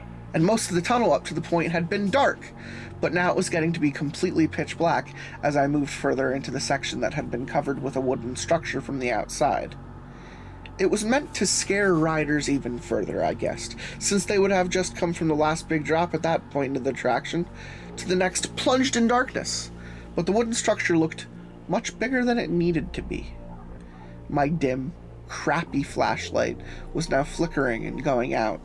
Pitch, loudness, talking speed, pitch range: 155 Hz, -25 LUFS, 200 wpm, 130-180 Hz